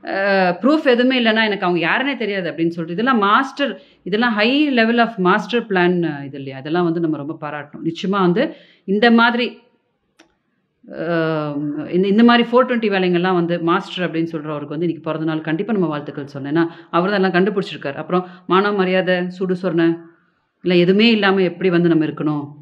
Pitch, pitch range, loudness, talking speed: 180 Hz, 165-210 Hz, -17 LUFS, 160 wpm